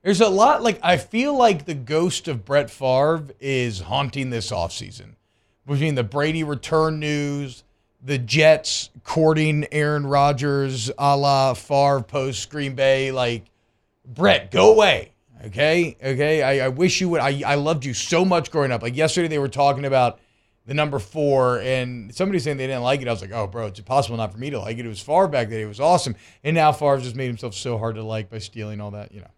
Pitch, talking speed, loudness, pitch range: 135 Hz, 210 wpm, -21 LUFS, 115-150 Hz